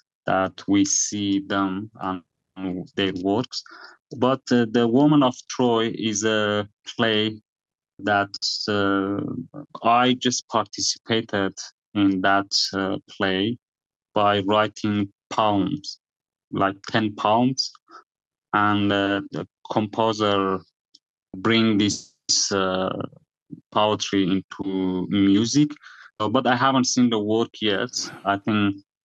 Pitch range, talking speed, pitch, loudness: 100-115 Hz, 105 wpm, 105 Hz, -22 LUFS